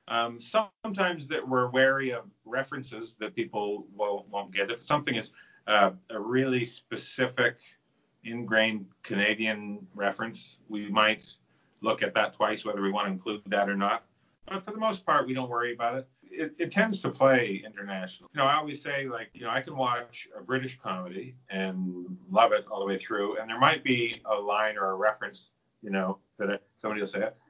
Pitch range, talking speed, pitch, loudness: 100-130 Hz, 195 wpm, 115 Hz, -29 LUFS